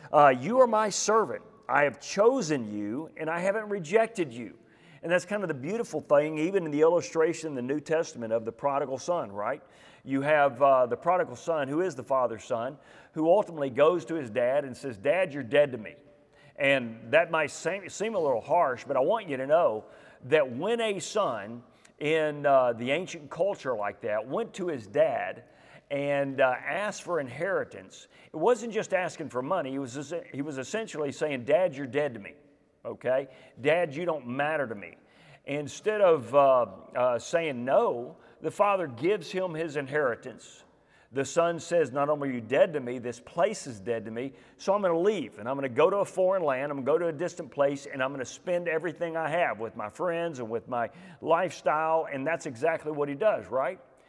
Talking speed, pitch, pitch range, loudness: 200 wpm, 150 Hz, 135-175 Hz, -28 LUFS